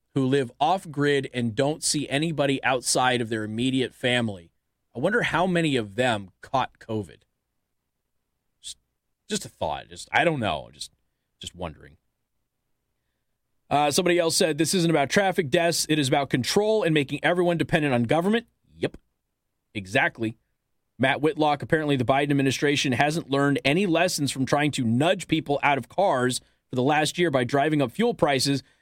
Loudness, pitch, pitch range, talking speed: -24 LUFS, 140 Hz, 125-160 Hz, 165 wpm